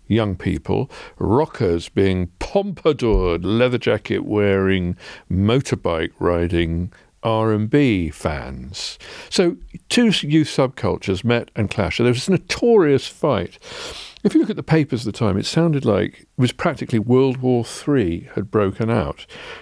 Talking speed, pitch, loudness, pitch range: 145 wpm, 110 Hz, -20 LUFS, 95-135 Hz